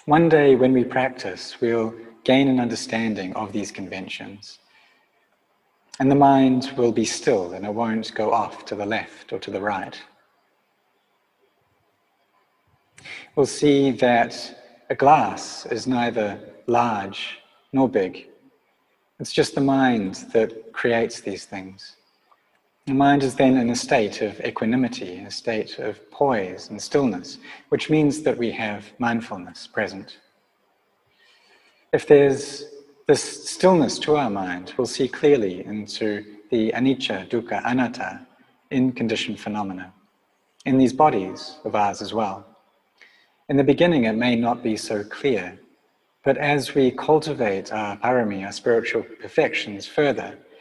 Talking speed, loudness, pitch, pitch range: 135 wpm, -22 LUFS, 120 Hz, 110-135 Hz